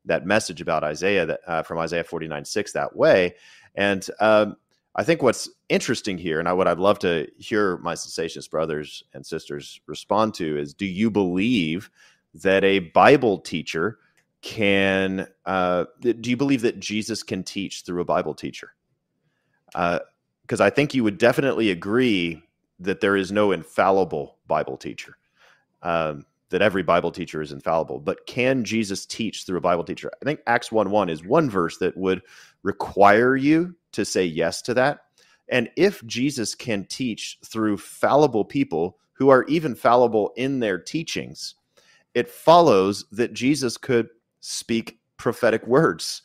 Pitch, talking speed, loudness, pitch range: 100 Hz, 160 wpm, -22 LUFS, 90-115 Hz